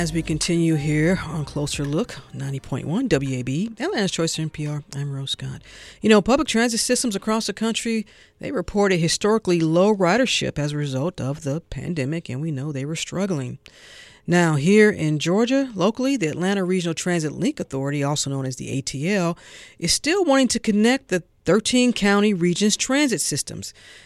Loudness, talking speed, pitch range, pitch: -21 LUFS, 165 wpm, 150-215 Hz, 170 Hz